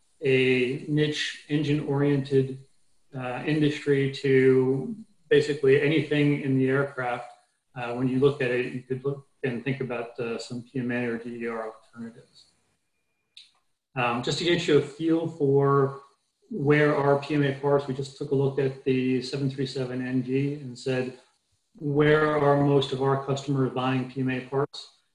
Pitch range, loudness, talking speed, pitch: 130-145 Hz, -26 LUFS, 145 wpm, 135 Hz